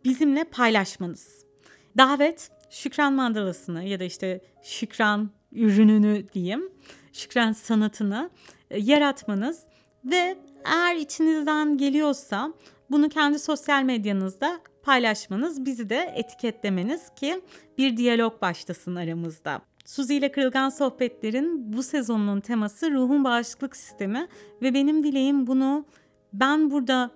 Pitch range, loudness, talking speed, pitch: 210-290 Hz, -24 LUFS, 105 wpm, 260 Hz